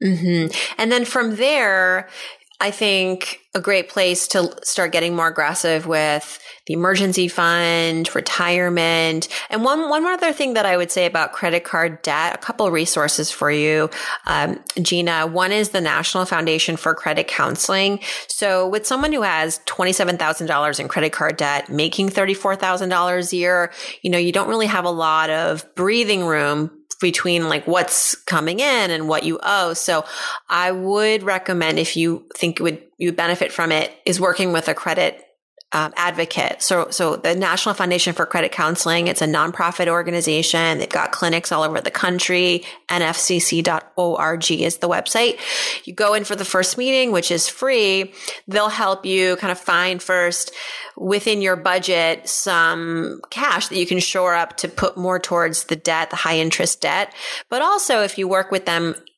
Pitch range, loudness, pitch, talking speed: 165-195 Hz, -19 LUFS, 180 Hz, 180 wpm